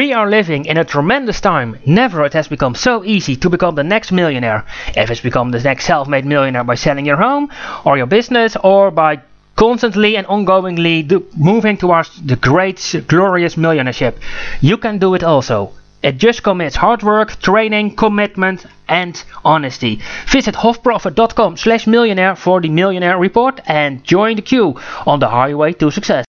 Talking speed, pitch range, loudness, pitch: 165 wpm, 145-215 Hz, -13 LUFS, 180 Hz